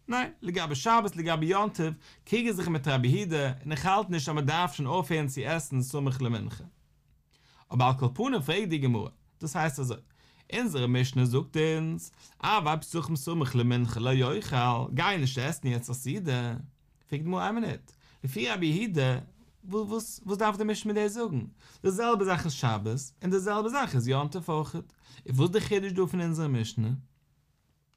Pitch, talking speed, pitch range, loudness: 155 Hz, 170 wpm, 130-190 Hz, -29 LUFS